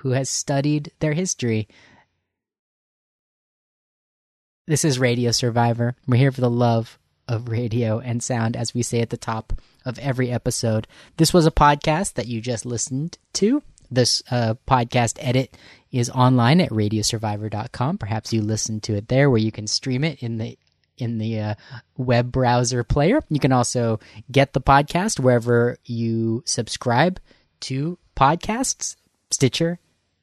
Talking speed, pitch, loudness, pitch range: 150 wpm, 120 Hz, -21 LUFS, 115-135 Hz